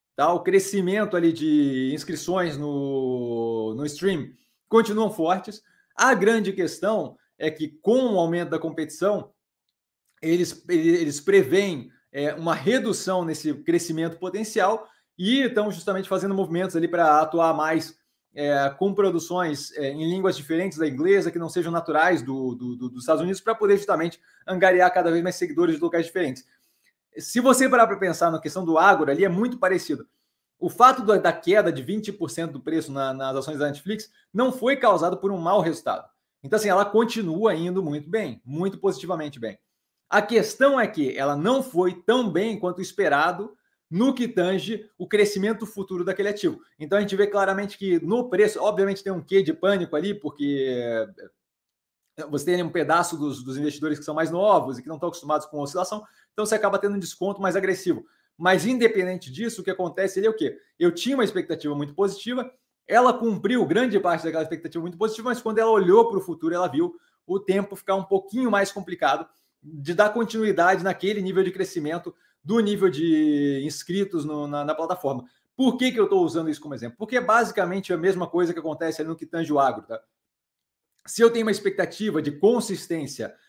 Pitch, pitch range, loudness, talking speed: 185 Hz, 160-210 Hz, -23 LUFS, 185 wpm